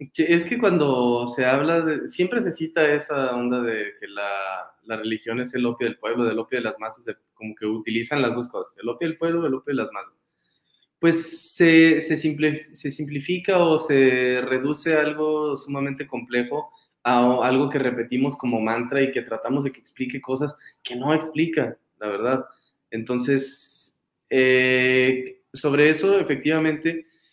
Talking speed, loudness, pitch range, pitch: 165 wpm, -22 LUFS, 125-155 Hz, 135 Hz